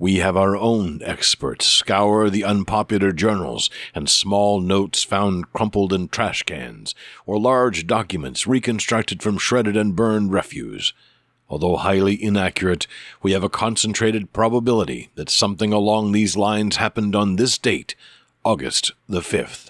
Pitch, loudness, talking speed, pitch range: 105 Hz, -19 LUFS, 140 wpm, 100-110 Hz